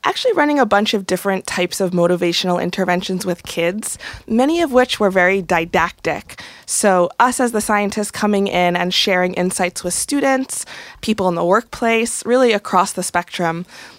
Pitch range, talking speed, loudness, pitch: 180-225 Hz, 165 wpm, -17 LUFS, 190 Hz